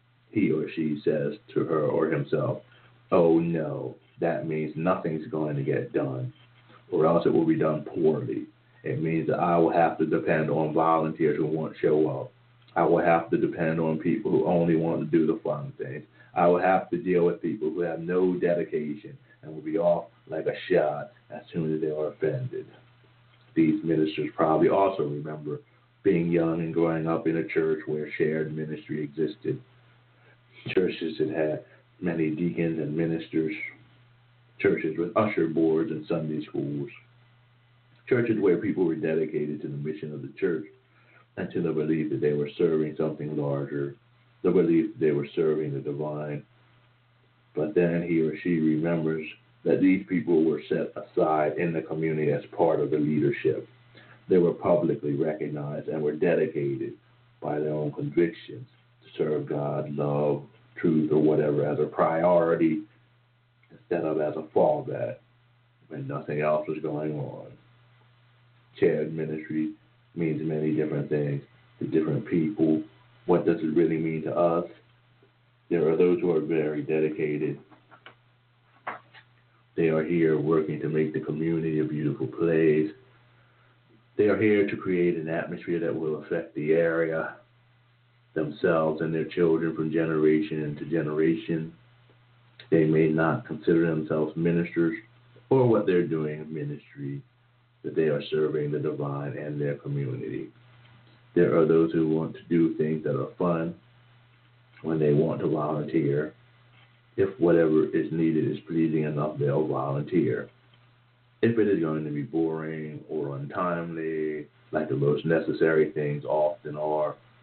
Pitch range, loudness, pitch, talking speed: 75-120 Hz, -27 LUFS, 80 Hz, 155 wpm